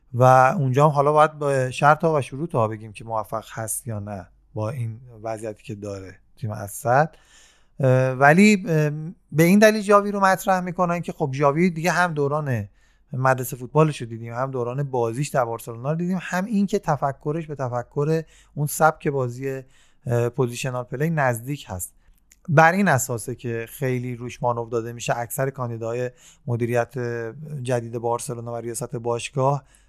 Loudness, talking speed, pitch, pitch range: -22 LUFS, 155 wpm, 130 Hz, 120-155 Hz